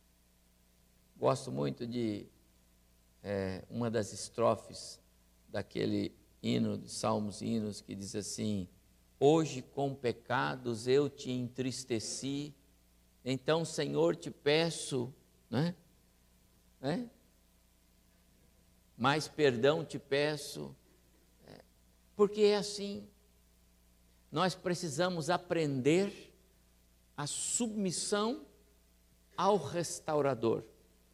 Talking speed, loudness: 80 wpm, -34 LUFS